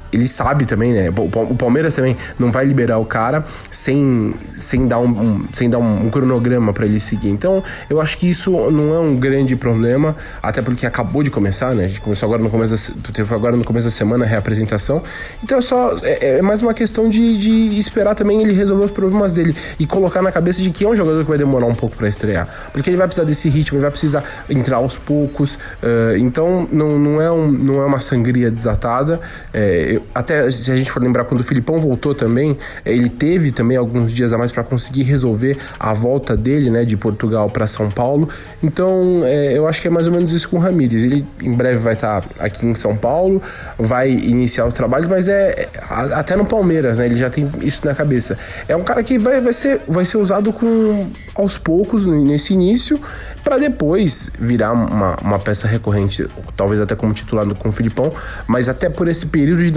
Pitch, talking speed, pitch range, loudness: 130 Hz, 215 wpm, 115-170 Hz, -16 LUFS